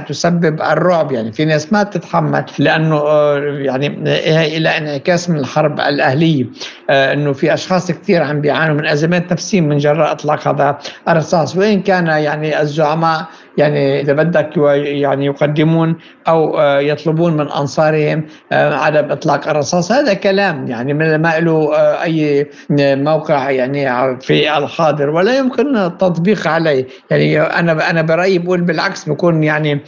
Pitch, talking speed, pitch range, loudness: 155 Hz, 135 wpm, 145-170 Hz, -14 LUFS